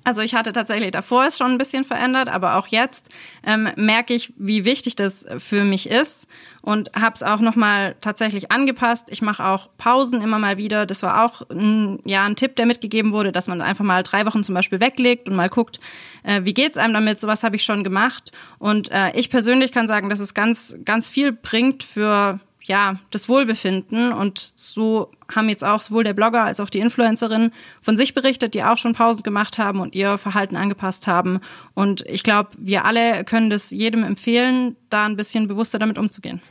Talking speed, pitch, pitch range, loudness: 205 wpm, 215 Hz, 200-235 Hz, -19 LUFS